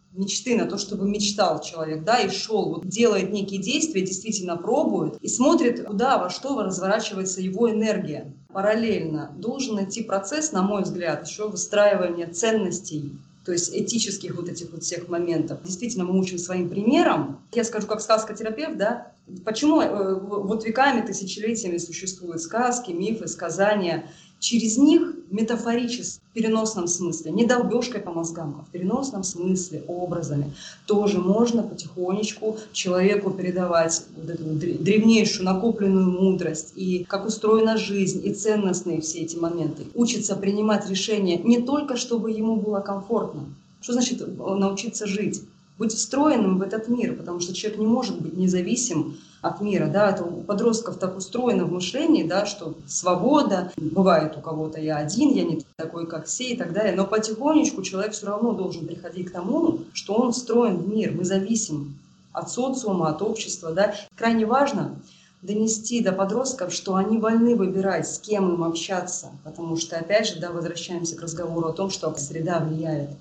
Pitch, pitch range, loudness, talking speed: 195 Hz, 175-220 Hz, -24 LUFS, 155 wpm